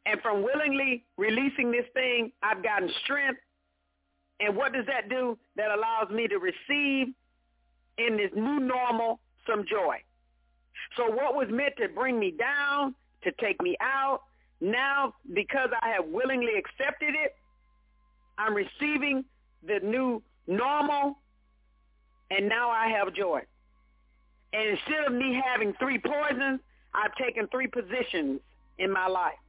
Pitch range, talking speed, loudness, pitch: 200-270 Hz, 140 wpm, -29 LUFS, 240 Hz